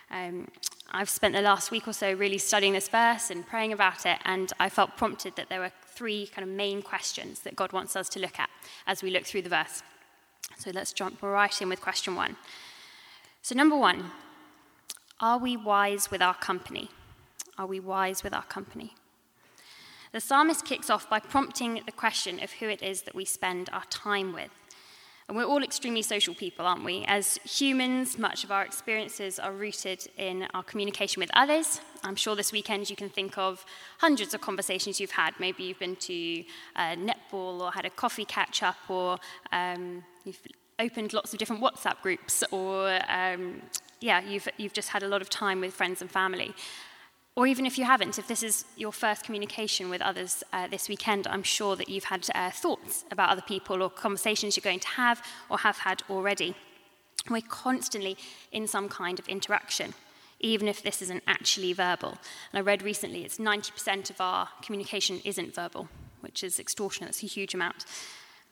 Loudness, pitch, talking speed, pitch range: -29 LUFS, 200 Hz, 190 wpm, 190-220 Hz